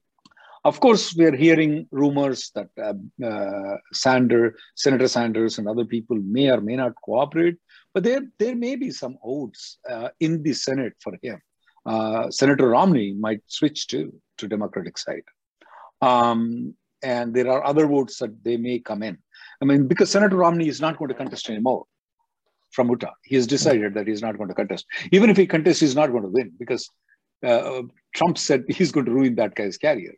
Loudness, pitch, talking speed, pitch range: -22 LUFS, 140 Hz, 190 wpm, 120-175 Hz